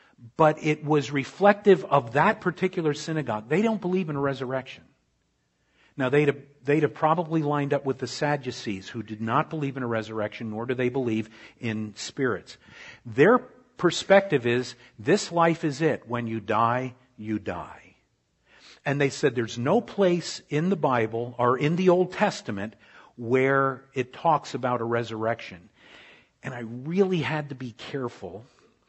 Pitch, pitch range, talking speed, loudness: 135 Hz, 120-160 Hz, 160 wpm, -25 LUFS